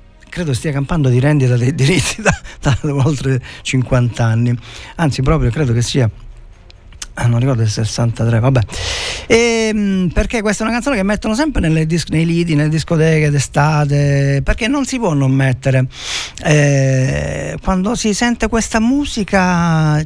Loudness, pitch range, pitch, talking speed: -15 LUFS, 125-185 Hz, 145 Hz, 160 wpm